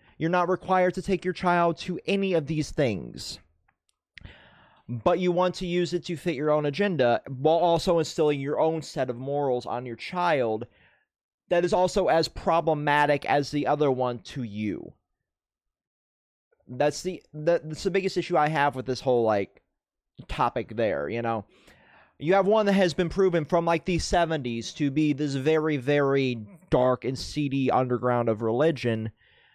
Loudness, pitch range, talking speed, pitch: -26 LUFS, 125-175 Hz, 170 wpm, 150 Hz